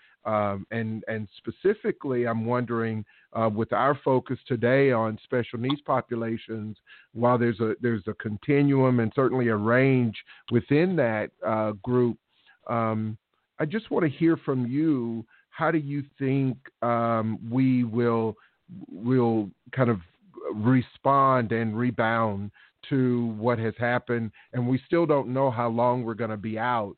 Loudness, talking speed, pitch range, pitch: -26 LUFS, 145 wpm, 110-130 Hz, 120 Hz